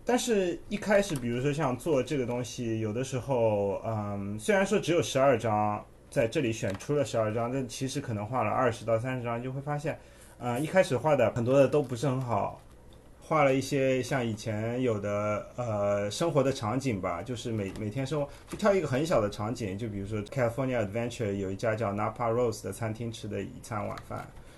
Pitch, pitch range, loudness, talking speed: 120 Hz, 105-135 Hz, -30 LUFS, 350 characters per minute